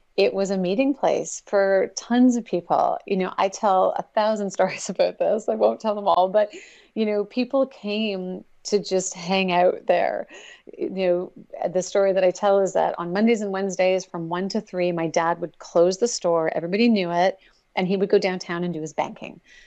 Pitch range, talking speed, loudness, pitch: 180-215 Hz, 205 wpm, -23 LUFS, 195 Hz